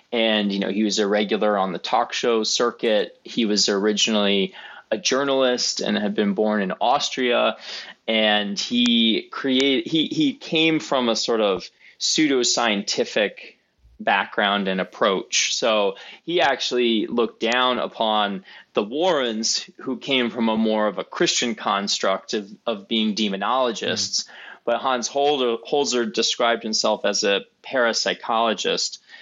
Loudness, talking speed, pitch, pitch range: -21 LUFS, 140 wpm, 115 Hz, 105-135 Hz